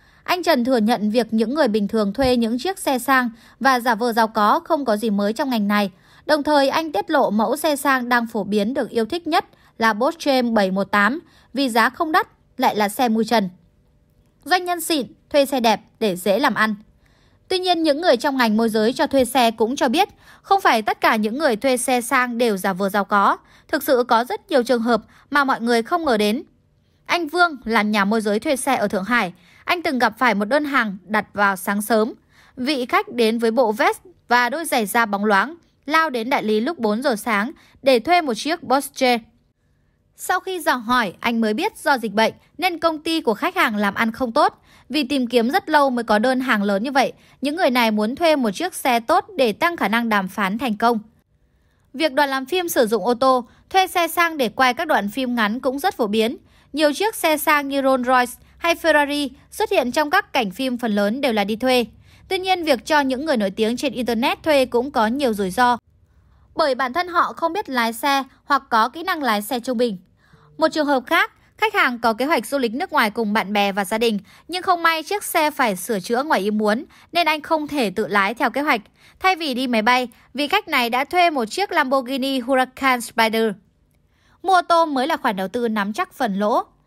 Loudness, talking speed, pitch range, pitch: -20 LUFS, 235 wpm, 225-305 Hz, 255 Hz